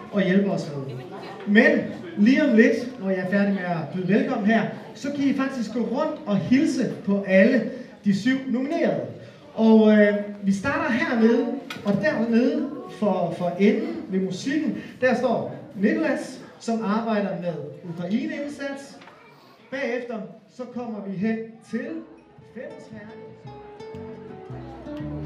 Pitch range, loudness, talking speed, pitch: 200-250 Hz, -23 LUFS, 135 wpm, 220 Hz